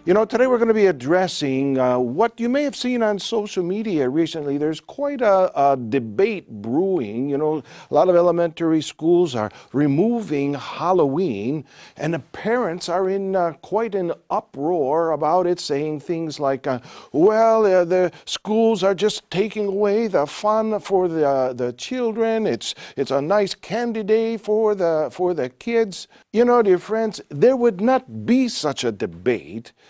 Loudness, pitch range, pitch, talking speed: -21 LUFS, 150-220 Hz, 185 Hz, 175 wpm